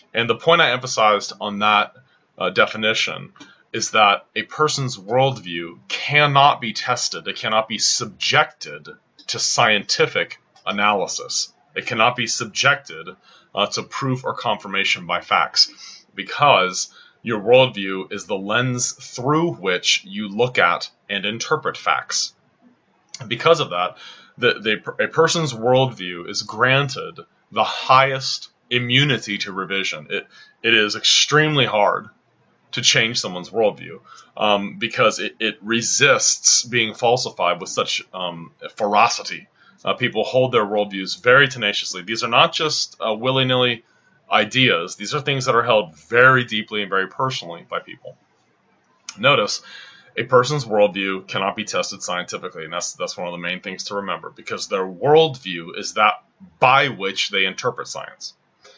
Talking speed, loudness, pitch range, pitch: 145 wpm, -19 LUFS, 105-145 Hz, 125 Hz